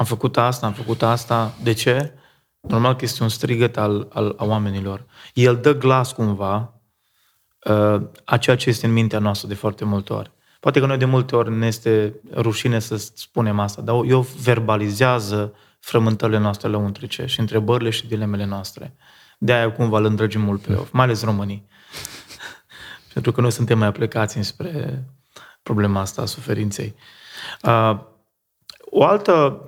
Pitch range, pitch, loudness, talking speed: 105-125 Hz, 115 Hz, -20 LUFS, 165 wpm